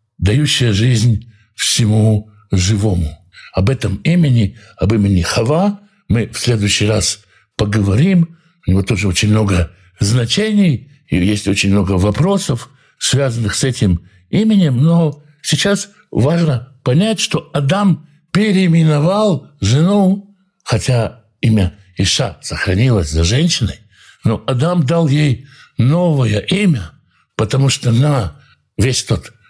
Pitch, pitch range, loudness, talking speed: 120 Hz, 105-160 Hz, -15 LUFS, 110 wpm